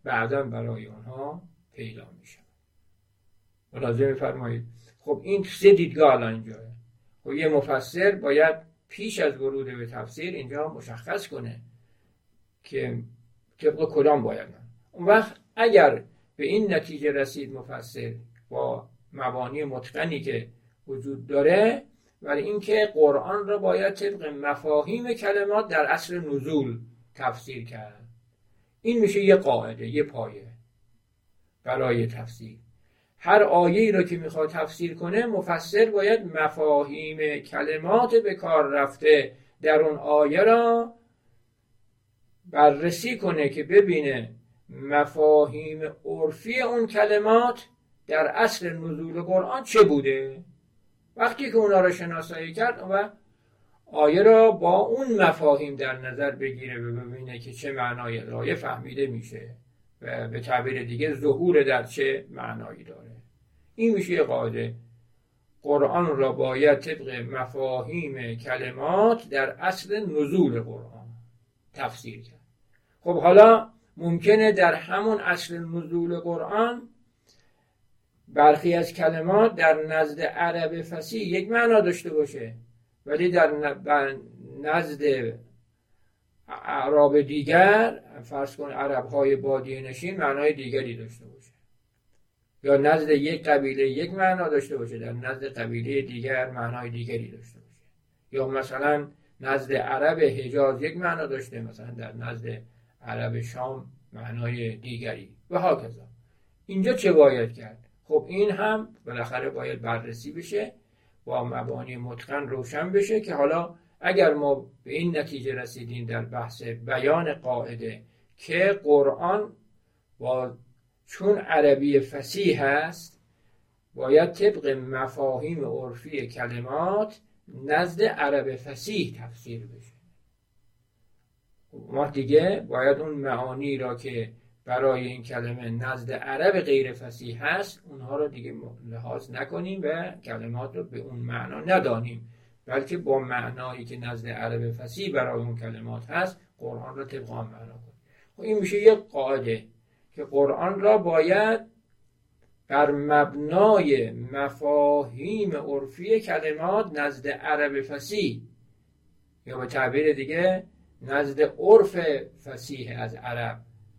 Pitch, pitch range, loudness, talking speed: 140 Hz, 120-170 Hz, -24 LUFS, 120 wpm